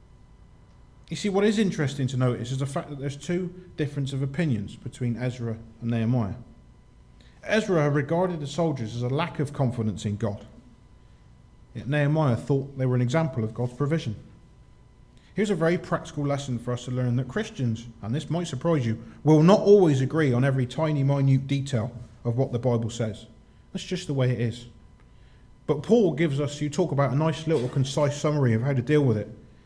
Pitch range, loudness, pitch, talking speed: 120-160 Hz, -26 LUFS, 135 Hz, 190 wpm